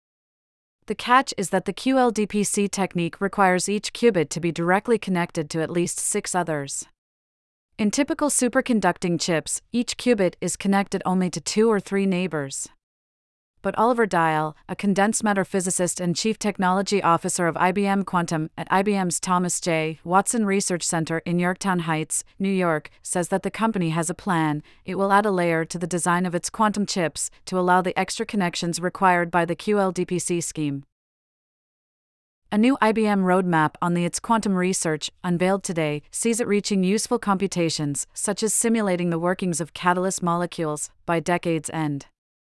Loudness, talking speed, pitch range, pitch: -23 LUFS, 160 wpm, 165-200 Hz, 180 Hz